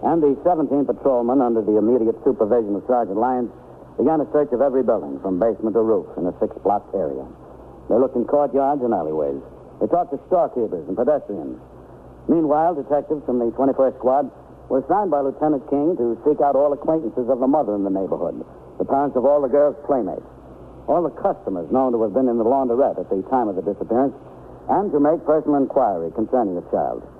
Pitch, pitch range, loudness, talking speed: 130 Hz, 110-145 Hz, -20 LUFS, 200 wpm